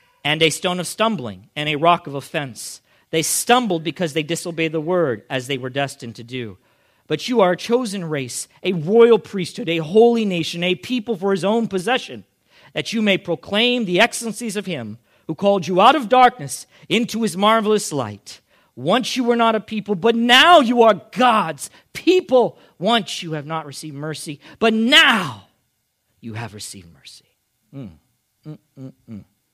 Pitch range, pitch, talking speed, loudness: 140-225 Hz, 175 Hz, 170 wpm, -18 LUFS